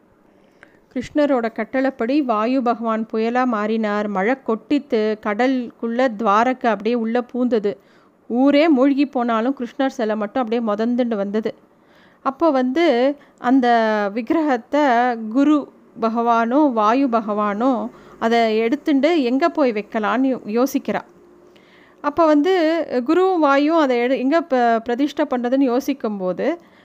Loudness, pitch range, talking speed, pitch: -19 LUFS, 225-280 Hz, 105 wpm, 250 Hz